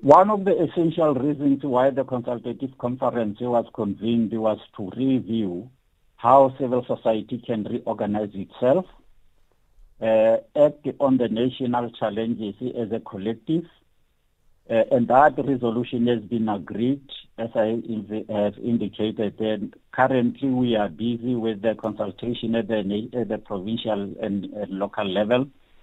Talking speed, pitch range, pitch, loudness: 130 wpm, 110-125 Hz, 115 Hz, -23 LUFS